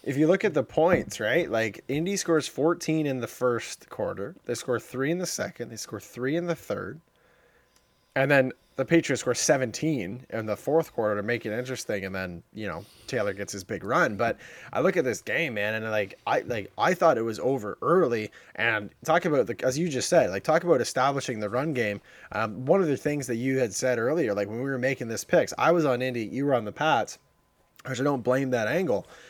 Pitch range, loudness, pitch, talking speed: 115-150 Hz, -27 LUFS, 130 Hz, 235 wpm